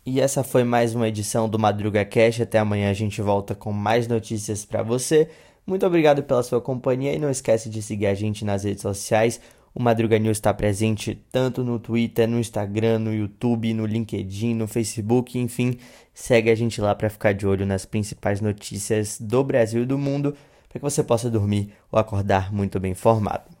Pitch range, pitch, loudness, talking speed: 105-120 Hz, 110 Hz, -23 LUFS, 195 wpm